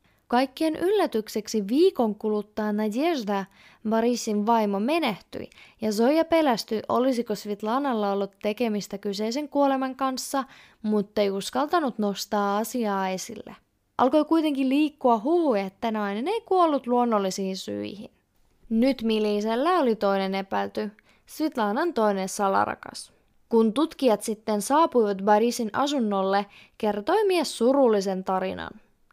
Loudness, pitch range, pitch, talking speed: -25 LUFS, 205-270 Hz, 225 Hz, 105 wpm